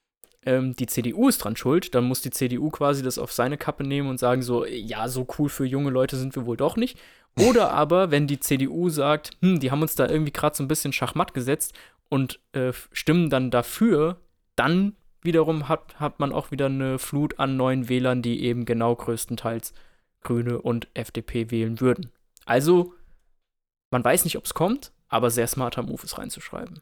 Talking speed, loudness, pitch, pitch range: 190 wpm, -24 LUFS, 135 Hz, 120-155 Hz